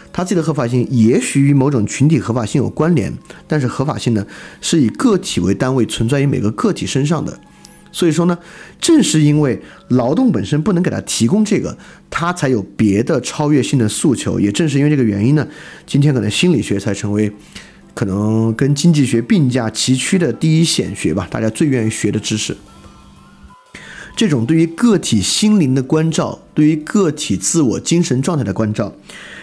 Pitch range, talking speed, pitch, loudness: 110-165 Hz, 290 characters per minute, 140 Hz, -15 LUFS